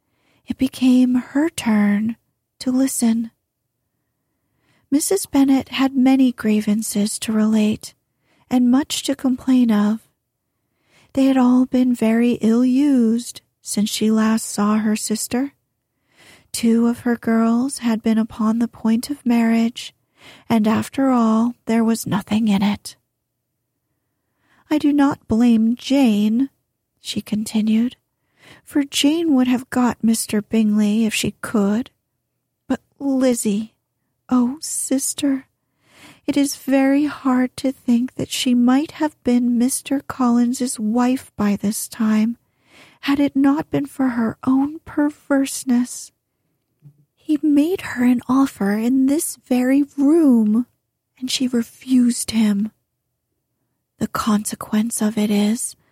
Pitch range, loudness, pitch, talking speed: 220-270 Hz, -19 LUFS, 245 Hz, 120 wpm